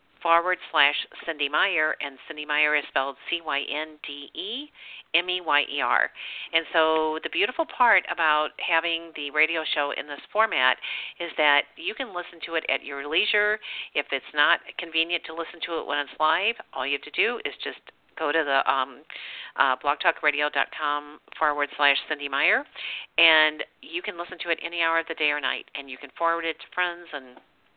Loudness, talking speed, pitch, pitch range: -25 LUFS, 195 wpm, 155 Hz, 145-170 Hz